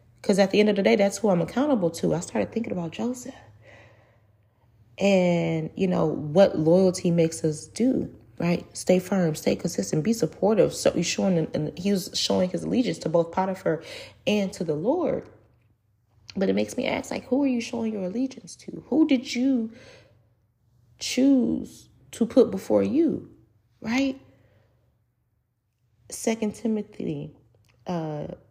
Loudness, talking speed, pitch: -25 LUFS, 155 wpm, 180 Hz